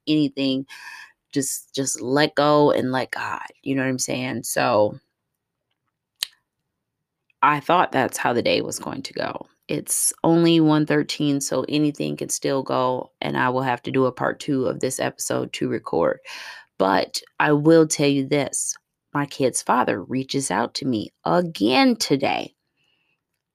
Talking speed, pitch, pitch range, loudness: 160 wpm, 140 Hz, 130-155 Hz, -22 LUFS